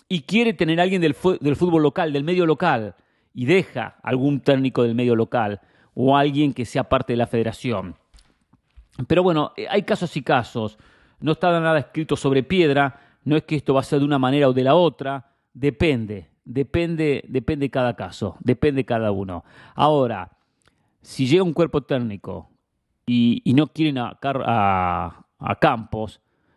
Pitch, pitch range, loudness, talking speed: 135 Hz, 115-155 Hz, -21 LUFS, 170 wpm